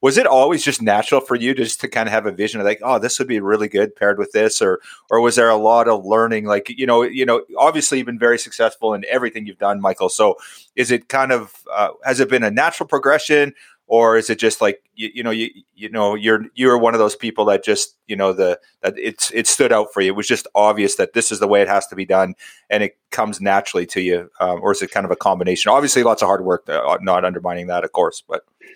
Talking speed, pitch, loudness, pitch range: 270 wpm, 115 Hz, -17 LUFS, 105-130 Hz